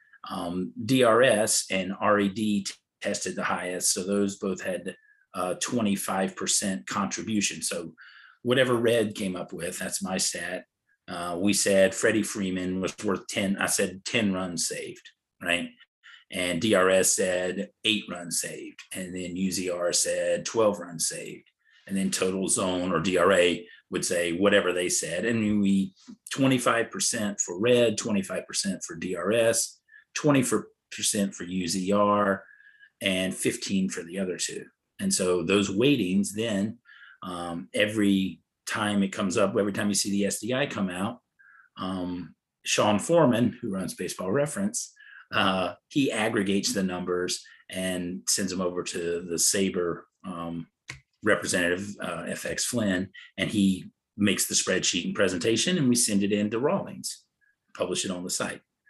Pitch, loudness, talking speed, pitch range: 100 Hz, -26 LUFS, 145 wpm, 90-110 Hz